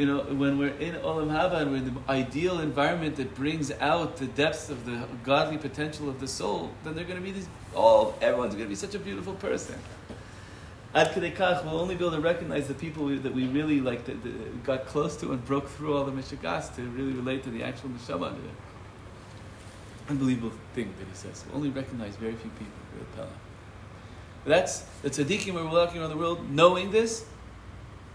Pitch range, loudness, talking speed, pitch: 110-150 Hz, -29 LUFS, 215 wpm, 135 Hz